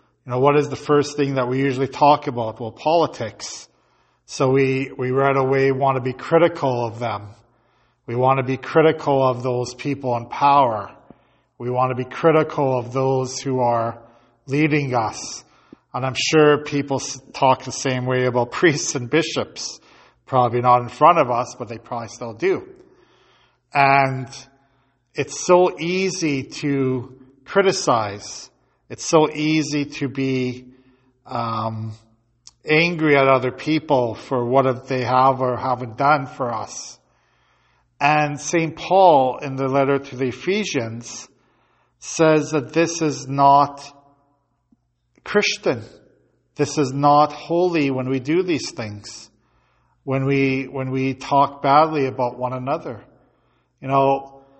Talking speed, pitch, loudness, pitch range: 140 wpm, 135 Hz, -20 LUFS, 125-145 Hz